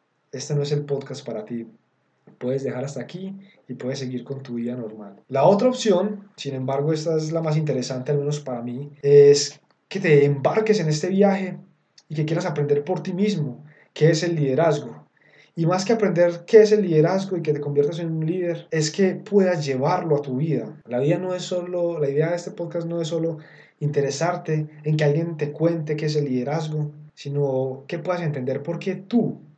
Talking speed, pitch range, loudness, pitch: 210 wpm, 145-175 Hz, -22 LUFS, 155 Hz